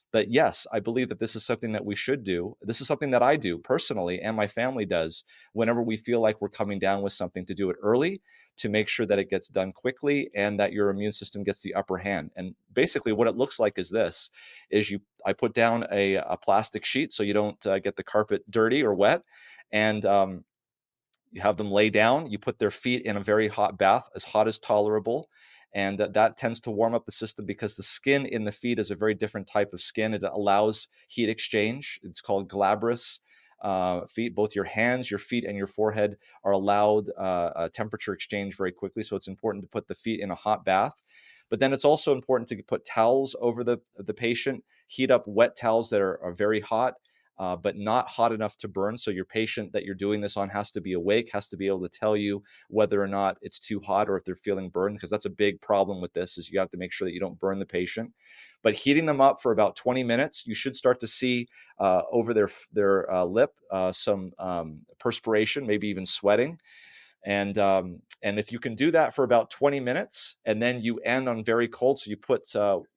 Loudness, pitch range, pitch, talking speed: -27 LUFS, 100-115 Hz, 105 Hz, 235 wpm